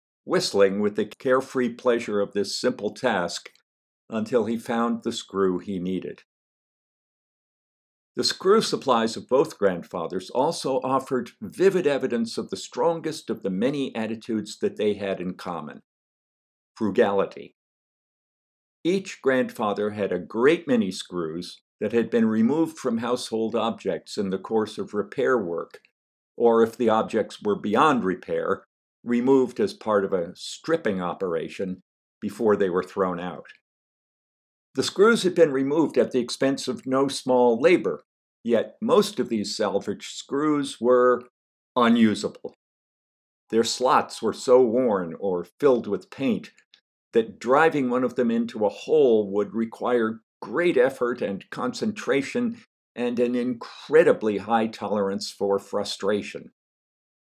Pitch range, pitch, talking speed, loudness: 105-135 Hz, 120 Hz, 135 wpm, -24 LUFS